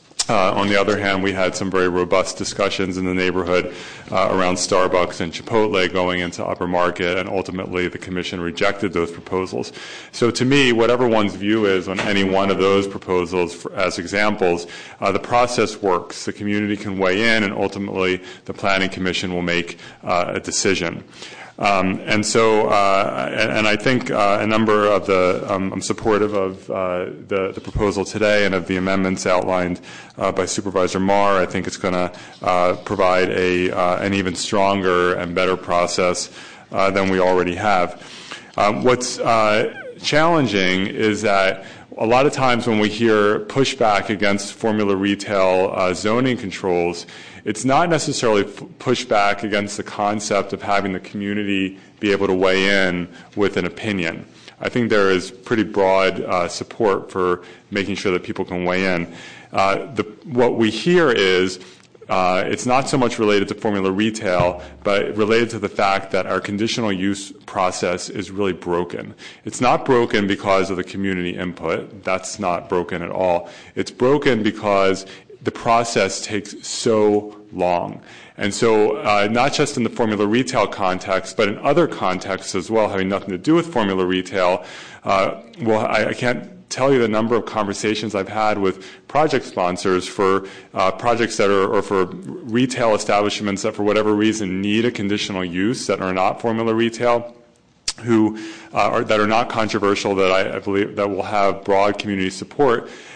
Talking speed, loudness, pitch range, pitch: 175 wpm, -19 LUFS, 95-110 Hz, 100 Hz